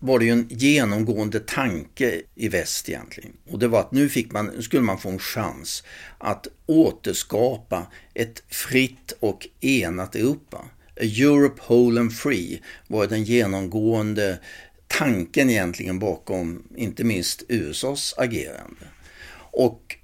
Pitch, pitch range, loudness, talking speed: 115 Hz, 100-125 Hz, -23 LUFS, 130 wpm